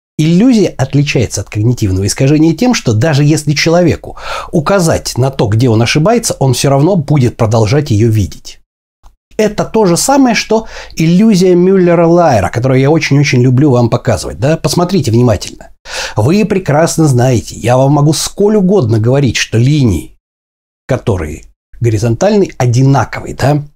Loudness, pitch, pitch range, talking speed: -10 LUFS, 140 Hz, 120-170 Hz, 140 wpm